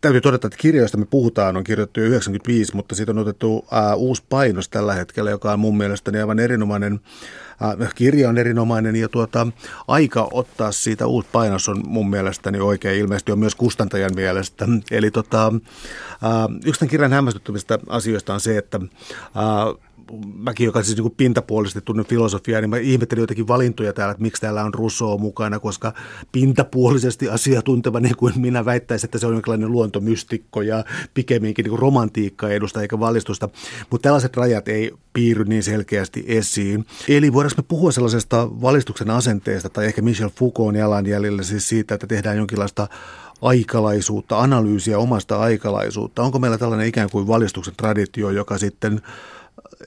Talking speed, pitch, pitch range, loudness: 160 wpm, 110 Hz, 105-120 Hz, -19 LUFS